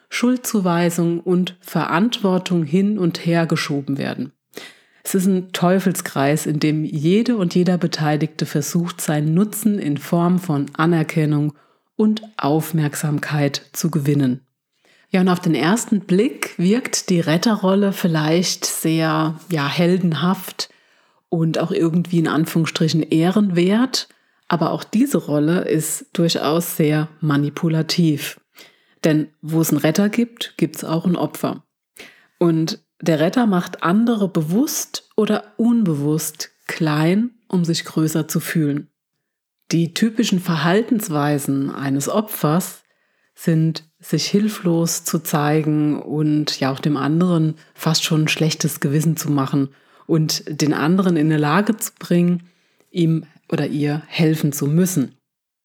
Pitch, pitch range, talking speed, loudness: 165 Hz, 155-185 Hz, 125 wpm, -19 LUFS